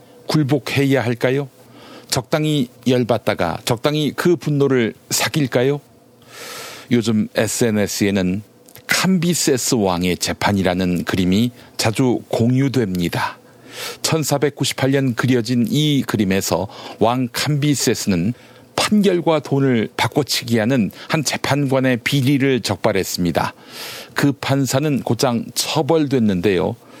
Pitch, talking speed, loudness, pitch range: 130 Hz, 235 characters per minute, -18 LUFS, 115-145 Hz